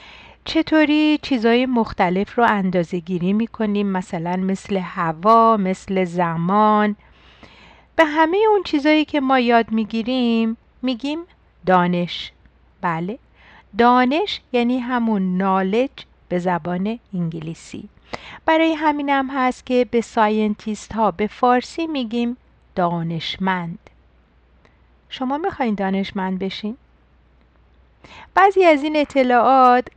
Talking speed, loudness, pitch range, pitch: 100 wpm, -19 LUFS, 185-255 Hz, 215 Hz